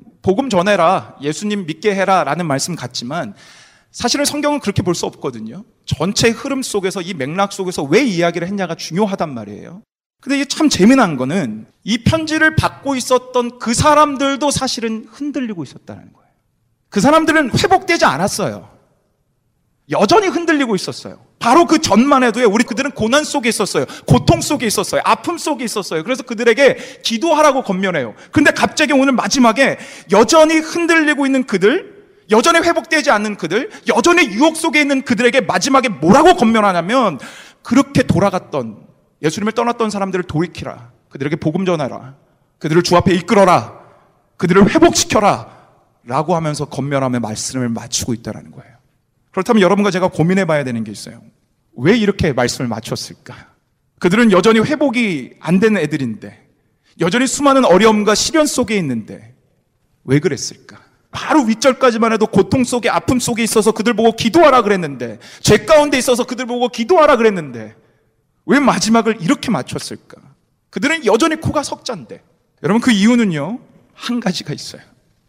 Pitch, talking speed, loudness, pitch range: 220 Hz, 370 characters per minute, -14 LUFS, 170-270 Hz